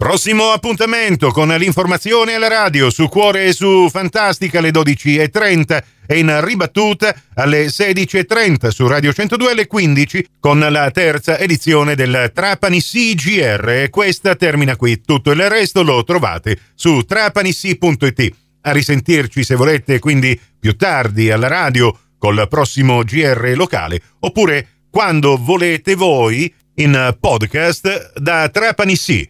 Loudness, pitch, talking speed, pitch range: -13 LUFS, 155 Hz, 130 wpm, 135-190 Hz